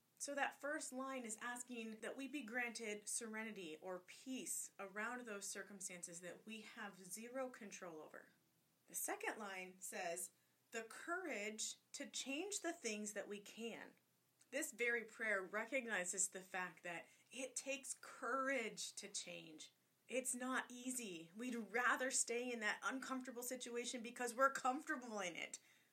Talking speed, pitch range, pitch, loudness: 145 wpm, 200-260 Hz, 230 Hz, -46 LUFS